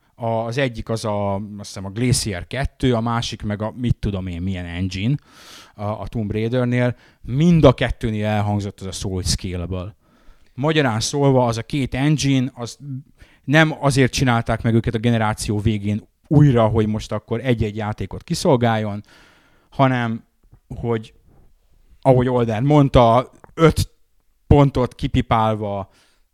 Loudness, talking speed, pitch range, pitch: -20 LUFS, 135 wpm, 105-130 Hz, 115 Hz